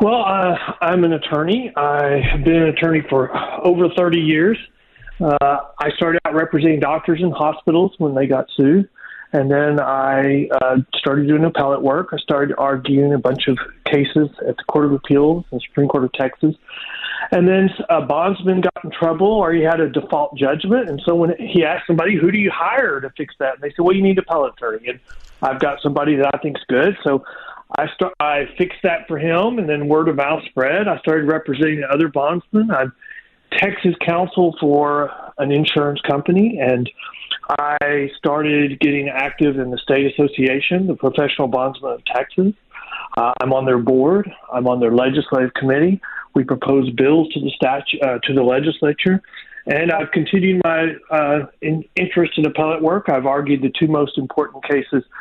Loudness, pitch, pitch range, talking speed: -17 LUFS, 150 Hz, 140-170 Hz, 185 wpm